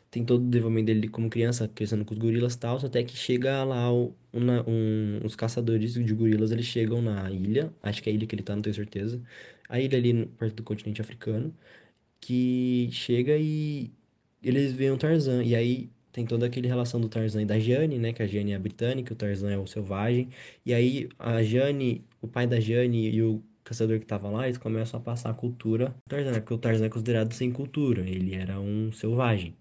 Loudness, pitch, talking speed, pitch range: -28 LUFS, 115 Hz, 220 wpm, 110-125 Hz